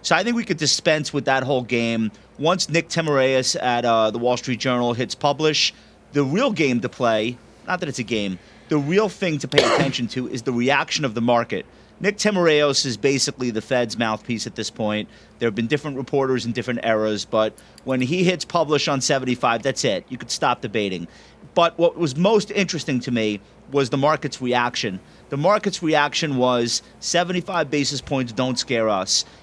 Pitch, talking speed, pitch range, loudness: 130 Hz, 195 wpm, 120-155 Hz, -21 LUFS